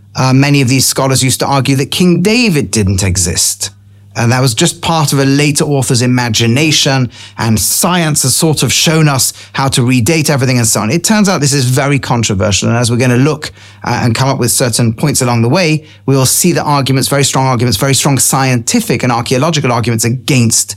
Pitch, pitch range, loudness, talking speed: 130 Hz, 115-145 Hz, -10 LUFS, 215 wpm